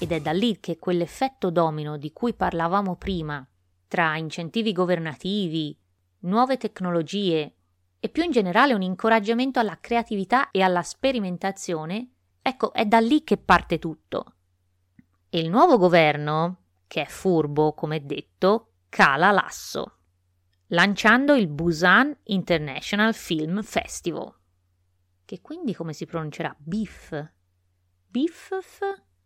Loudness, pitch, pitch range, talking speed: -23 LUFS, 175 Hz, 150-220 Hz, 120 wpm